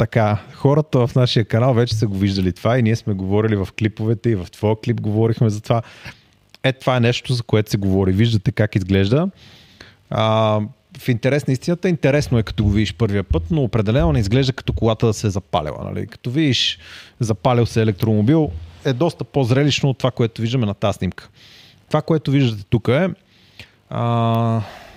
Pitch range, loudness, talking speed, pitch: 105-130 Hz, -19 LUFS, 185 wpm, 115 Hz